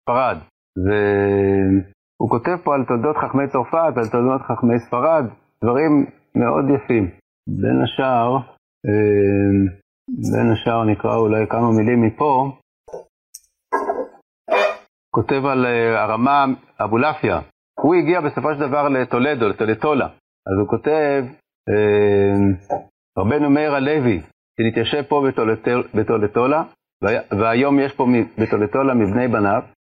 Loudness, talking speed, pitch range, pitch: -18 LUFS, 100 wpm, 105-140 Hz, 120 Hz